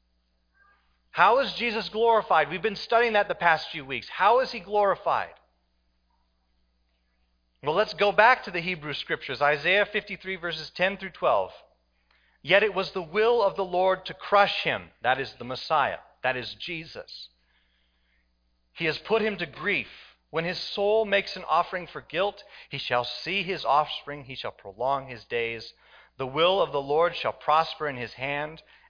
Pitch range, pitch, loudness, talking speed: 120-200 Hz, 165 Hz, -26 LUFS, 170 wpm